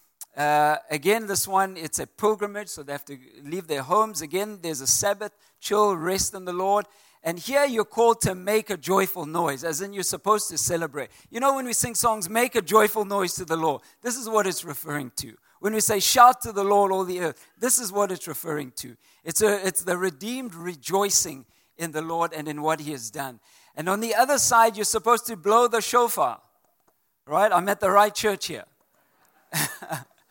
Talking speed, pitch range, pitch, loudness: 210 wpm, 160-215 Hz, 195 Hz, -23 LUFS